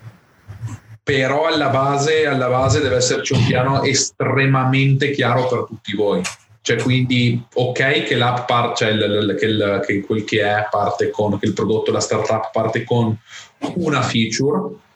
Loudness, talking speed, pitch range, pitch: -18 LUFS, 150 wpm, 110-135 Hz, 125 Hz